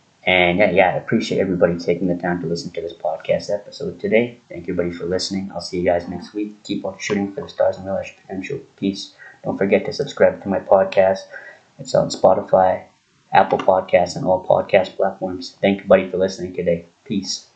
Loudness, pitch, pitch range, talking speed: -19 LUFS, 95 Hz, 85-100 Hz, 210 wpm